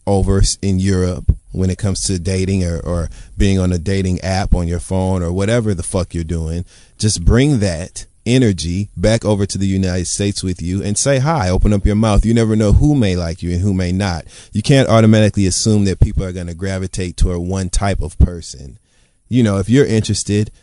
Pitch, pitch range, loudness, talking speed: 95 Hz, 90-105 Hz, -16 LUFS, 215 wpm